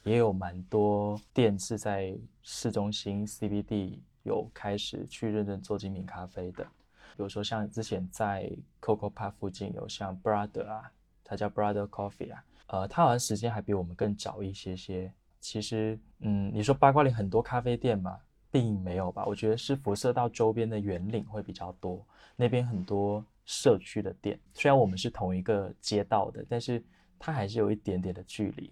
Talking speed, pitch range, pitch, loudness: 310 characters per minute, 100-110 Hz, 105 Hz, -31 LUFS